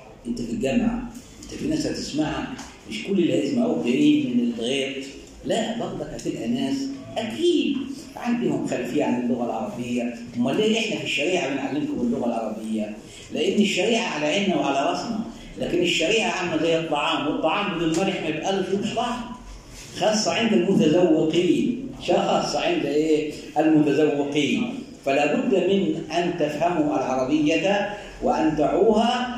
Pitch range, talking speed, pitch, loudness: 150-240 Hz, 130 wpm, 185 Hz, -23 LUFS